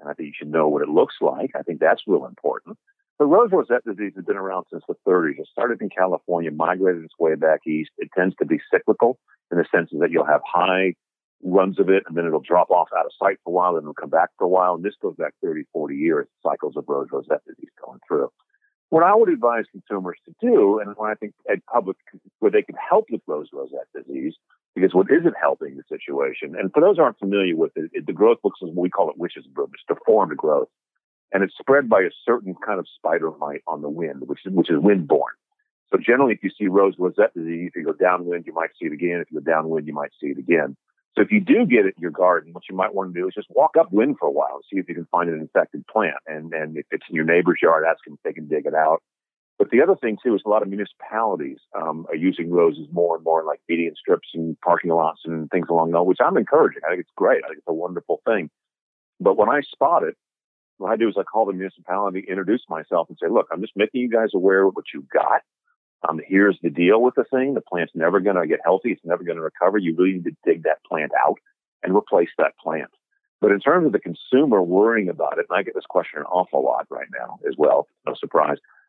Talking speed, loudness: 260 wpm, -21 LUFS